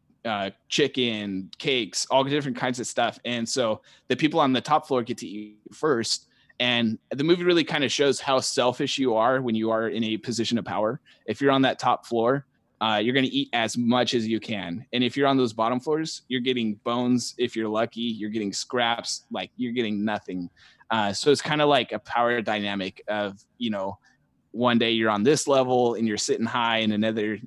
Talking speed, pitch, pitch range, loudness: 215 wpm, 120 Hz, 110-130 Hz, -25 LUFS